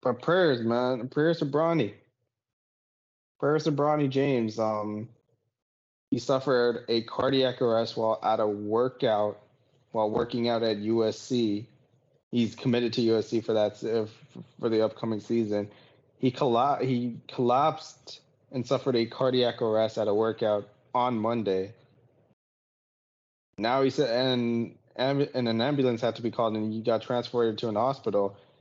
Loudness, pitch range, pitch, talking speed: -27 LUFS, 110-130 Hz, 115 Hz, 145 wpm